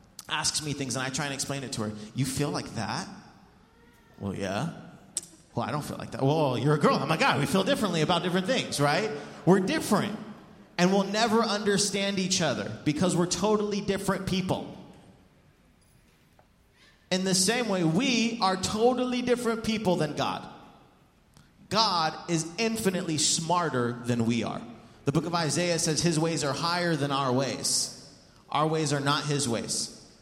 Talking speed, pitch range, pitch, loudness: 175 wpm, 140-200 Hz, 165 Hz, -27 LUFS